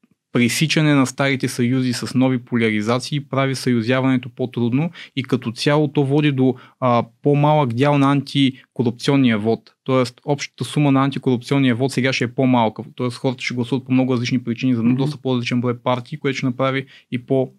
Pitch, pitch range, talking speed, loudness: 130 Hz, 125-140 Hz, 175 wpm, -19 LUFS